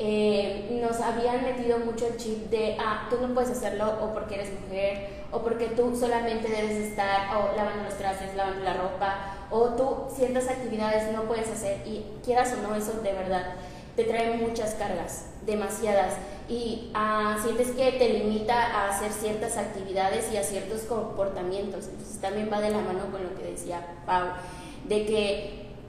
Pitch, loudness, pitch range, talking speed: 215 Hz, -28 LUFS, 200-230 Hz, 175 wpm